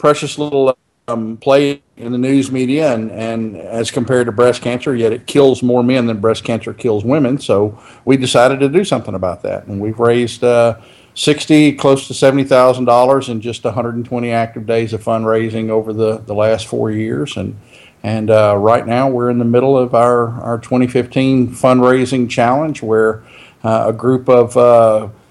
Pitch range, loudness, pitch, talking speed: 115-130 Hz, -14 LUFS, 120 Hz, 190 wpm